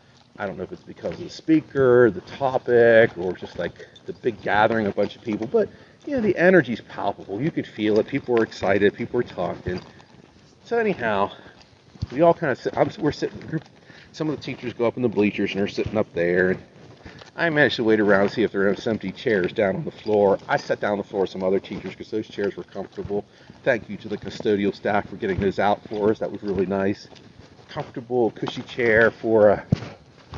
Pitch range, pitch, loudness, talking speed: 100-135 Hz, 115 Hz, -23 LUFS, 230 wpm